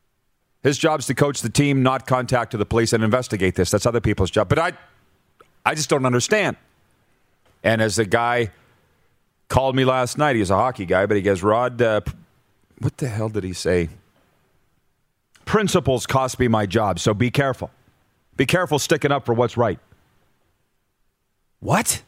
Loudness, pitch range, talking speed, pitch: -20 LUFS, 105-135 Hz, 175 wpm, 120 Hz